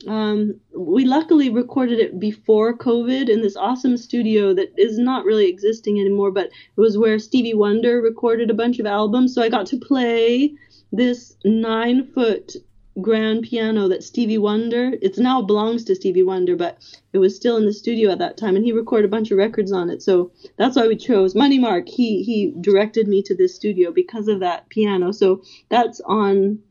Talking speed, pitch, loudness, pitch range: 195 wpm, 225 Hz, -19 LUFS, 210-245 Hz